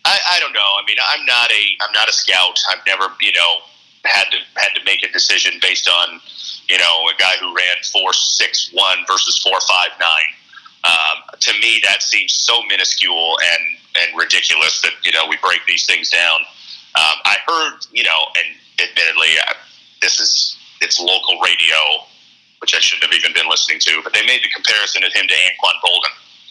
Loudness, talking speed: -13 LUFS, 200 wpm